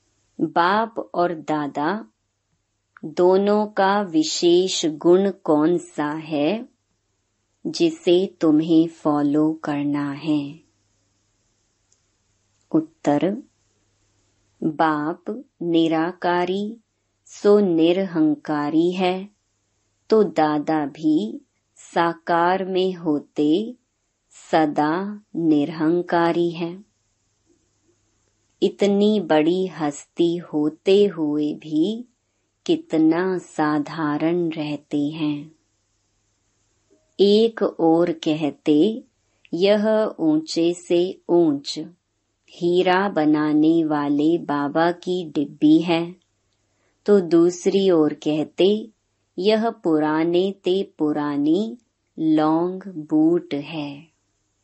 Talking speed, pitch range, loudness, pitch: 70 wpm, 145-185 Hz, -21 LUFS, 160 Hz